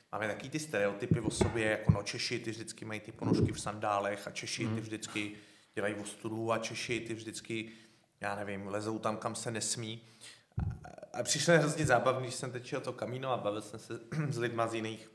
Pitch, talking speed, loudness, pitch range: 115 Hz, 200 wpm, -35 LUFS, 110-120 Hz